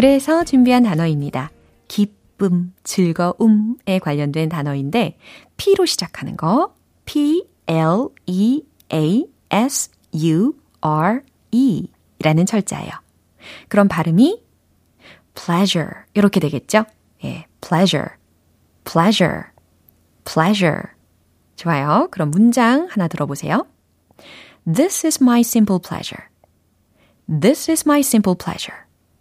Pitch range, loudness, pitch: 160-245 Hz, -18 LUFS, 190 Hz